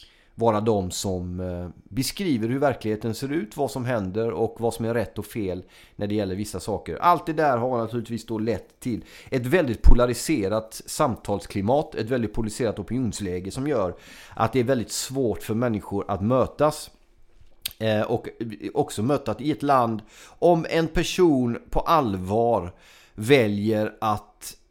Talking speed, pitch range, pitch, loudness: 155 wpm, 105-130 Hz, 115 Hz, -25 LUFS